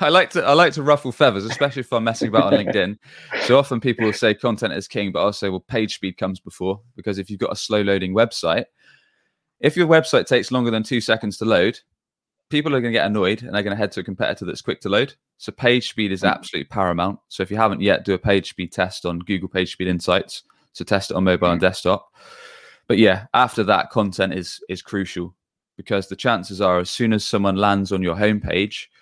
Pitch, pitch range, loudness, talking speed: 100 Hz, 95-115 Hz, -20 LUFS, 240 wpm